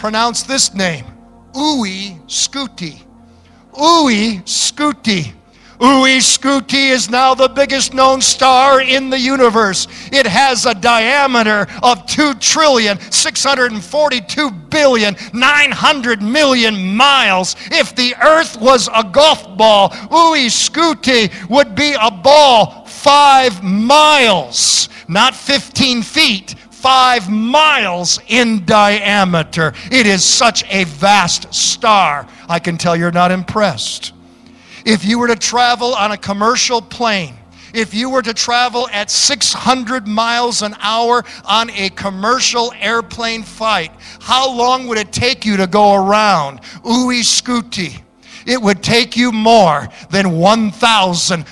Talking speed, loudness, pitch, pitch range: 120 wpm, -11 LUFS, 230 Hz, 205-260 Hz